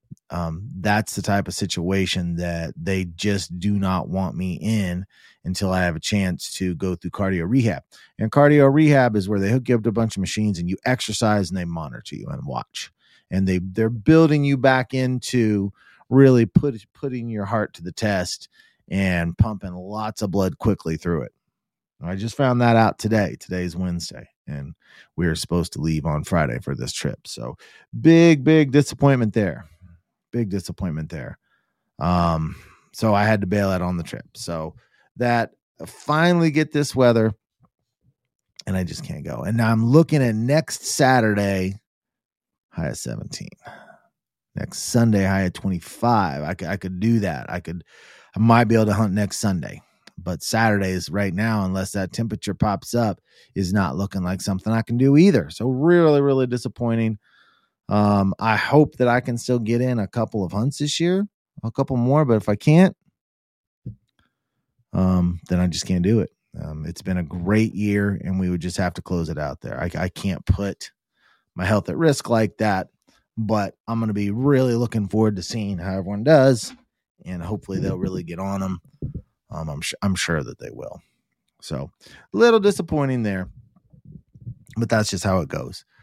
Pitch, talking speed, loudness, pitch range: 105 Hz, 185 wpm, -21 LUFS, 90-120 Hz